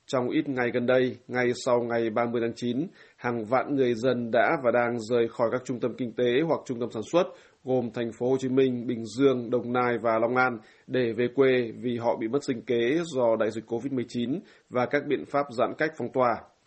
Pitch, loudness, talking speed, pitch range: 125 Hz, -27 LUFS, 230 wpm, 120-130 Hz